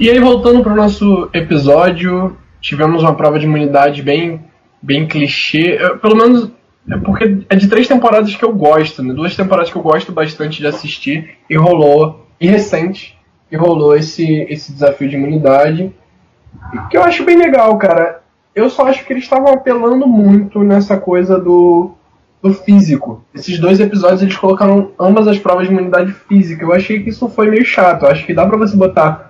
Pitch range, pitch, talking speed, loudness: 155-210 Hz, 180 Hz, 185 wpm, -11 LUFS